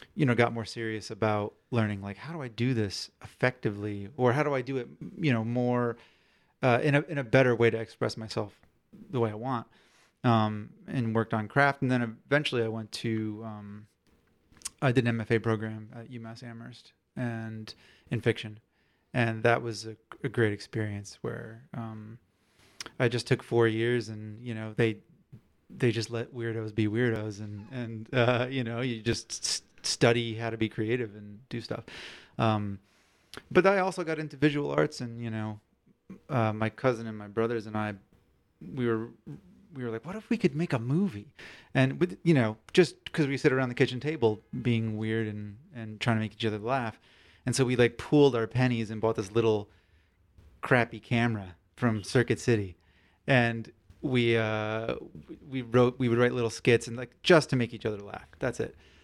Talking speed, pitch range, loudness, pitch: 190 wpm, 110-125 Hz, -29 LUFS, 115 Hz